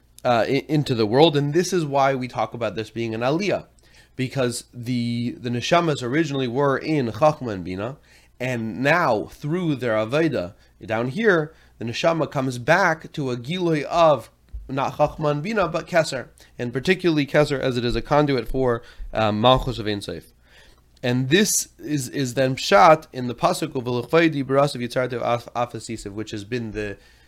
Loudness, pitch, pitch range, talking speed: -22 LUFS, 130 Hz, 120-150 Hz, 165 wpm